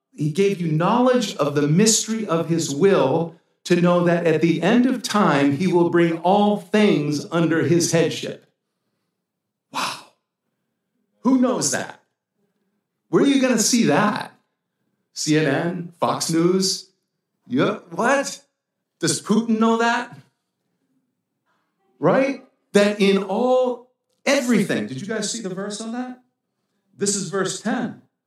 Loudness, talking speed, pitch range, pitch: -20 LUFS, 135 wpm, 170-230 Hz, 200 Hz